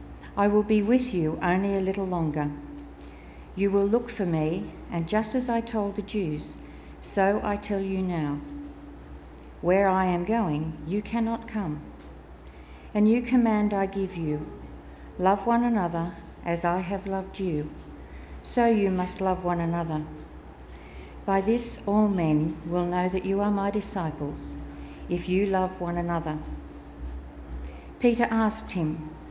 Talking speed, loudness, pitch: 145 wpm, -27 LUFS, 175 Hz